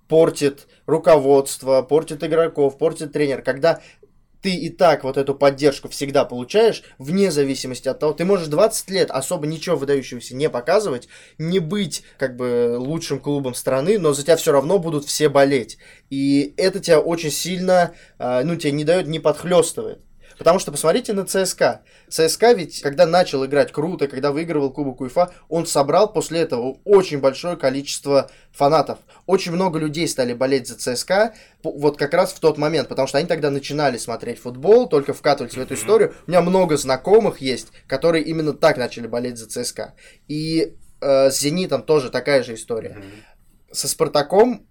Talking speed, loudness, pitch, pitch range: 165 wpm, -19 LUFS, 150 Hz, 135-170 Hz